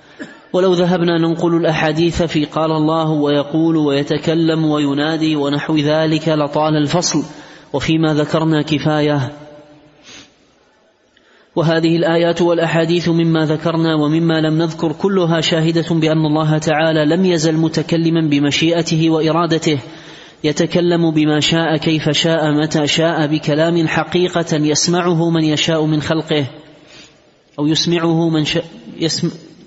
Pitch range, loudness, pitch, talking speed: 155-165 Hz, -15 LUFS, 160 Hz, 110 wpm